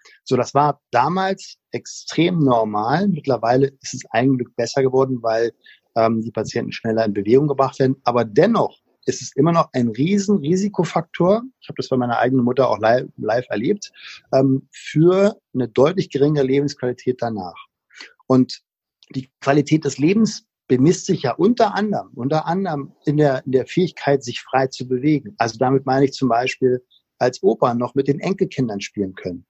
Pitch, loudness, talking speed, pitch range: 135 Hz, -19 LUFS, 170 wpm, 125-155 Hz